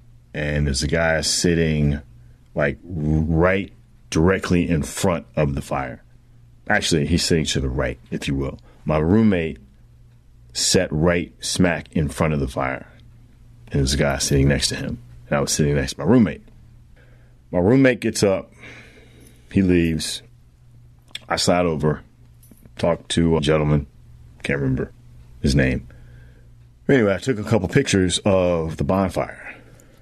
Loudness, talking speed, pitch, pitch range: -21 LUFS, 150 wpm, 75 Hz, 70-95 Hz